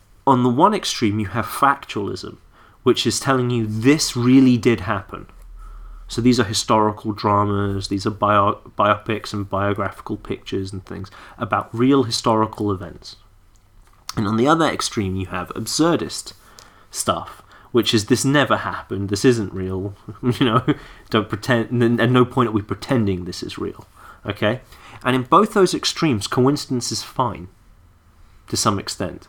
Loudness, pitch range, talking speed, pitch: -20 LUFS, 100-125 Hz, 155 wpm, 110 Hz